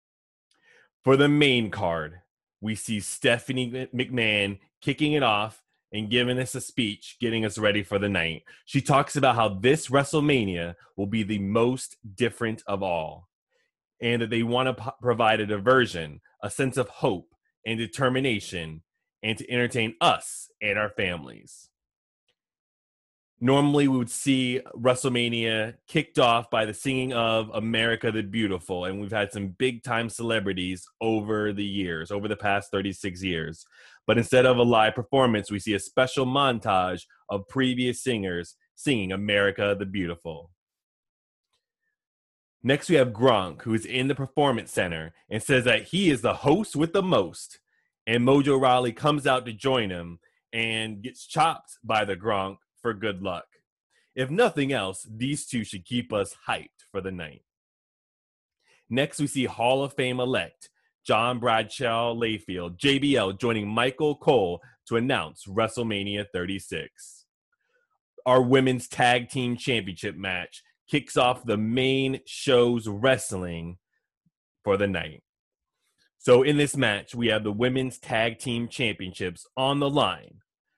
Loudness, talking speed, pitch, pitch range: -25 LUFS, 150 wpm, 115 Hz, 100-130 Hz